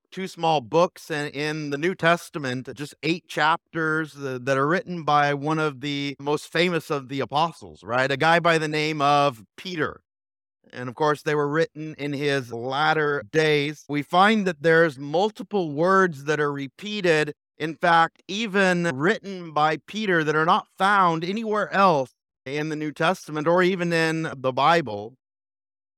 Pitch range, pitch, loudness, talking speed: 140-170 Hz, 155 Hz, -23 LUFS, 165 wpm